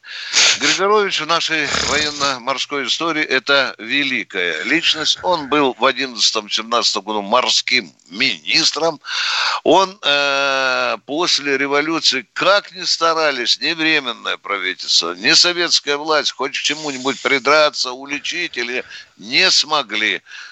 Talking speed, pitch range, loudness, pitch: 105 wpm, 135-165 Hz, -16 LUFS, 145 Hz